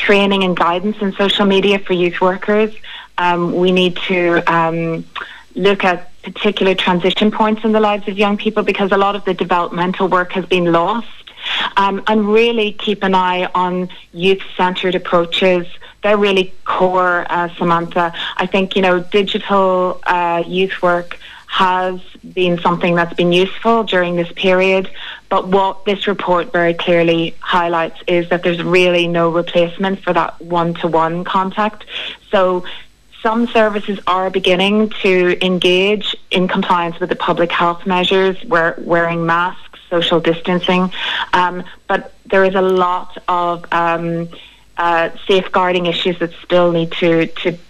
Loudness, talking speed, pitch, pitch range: -15 LUFS, 150 wpm, 185 Hz, 175-195 Hz